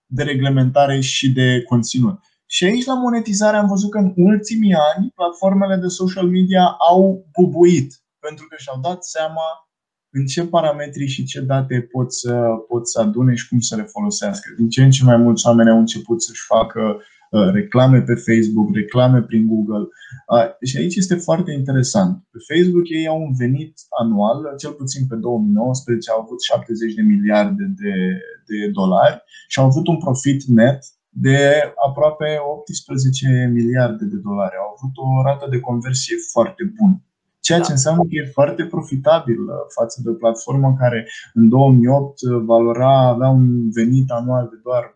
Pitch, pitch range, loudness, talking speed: 135 Hz, 120-175 Hz, -16 LUFS, 165 wpm